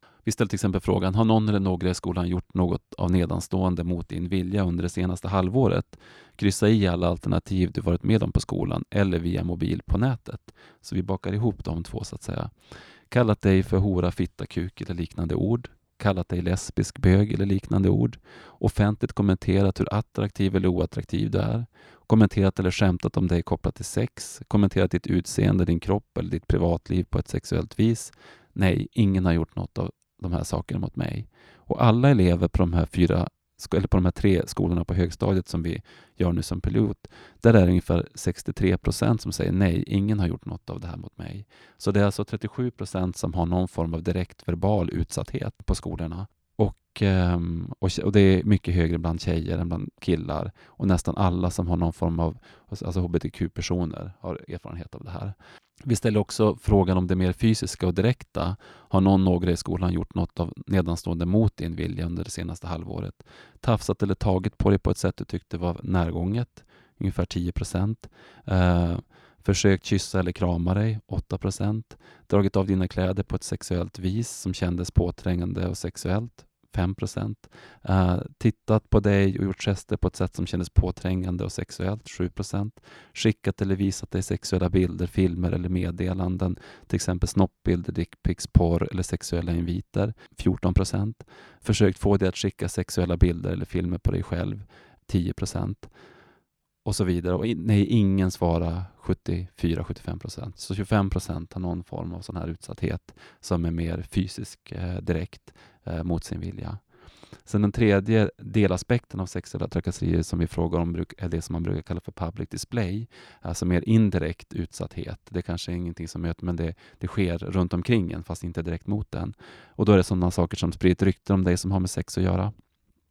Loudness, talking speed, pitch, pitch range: -26 LUFS, 180 wpm, 95 Hz, 85-105 Hz